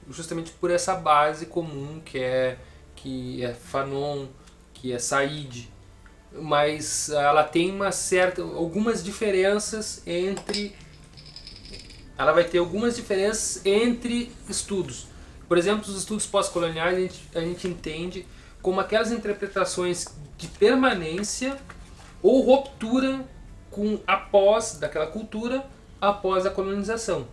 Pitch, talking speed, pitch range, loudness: 180 Hz, 115 wpm, 145-205 Hz, -25 LUFS